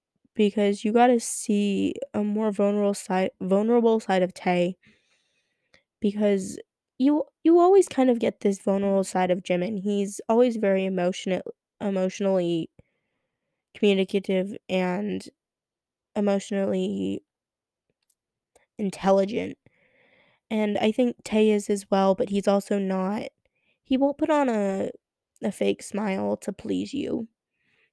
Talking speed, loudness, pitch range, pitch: 120 wpm, -25 LUFS, 190-225 Hz, 200 Hz